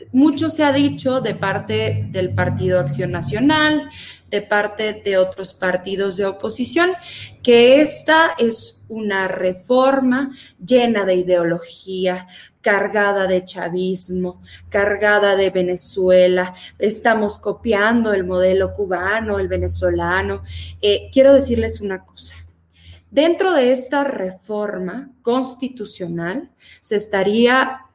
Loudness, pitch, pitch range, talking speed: -17 LUFS, 200 Hz, 180-250 Hz, 105 wpm